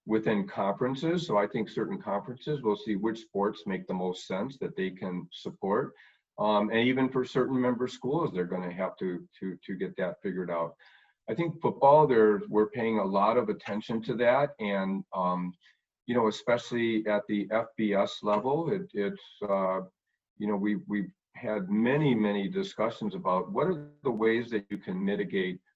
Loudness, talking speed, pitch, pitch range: -30 LUFS, 180 wpm, 105 Hz, 95-125 Hz